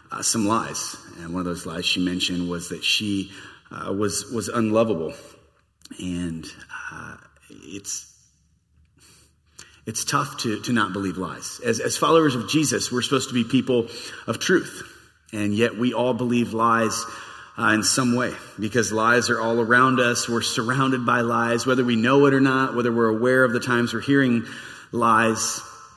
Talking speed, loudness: 170 wpm, -22 LUFS